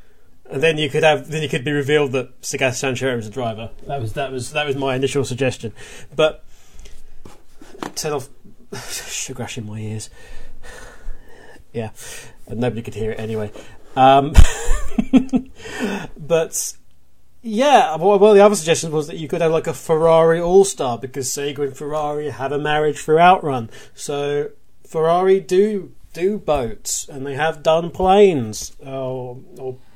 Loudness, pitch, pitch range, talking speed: -19 LUFS, 145 Hz, 130-165 Hz, 155 wpm